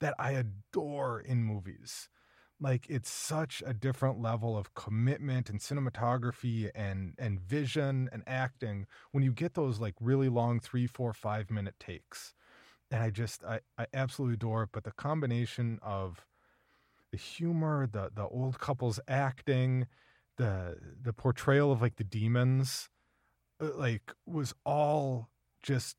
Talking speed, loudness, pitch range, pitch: 145 wpm, -34 LUFS, 110-135 Hz, 125 Hz